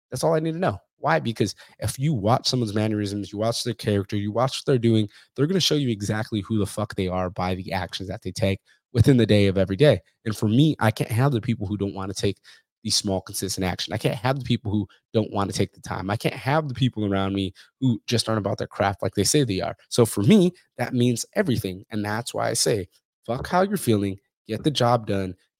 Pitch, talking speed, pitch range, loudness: 110 Hz, 260 wpm, 100-125 Hz, -24 LUFS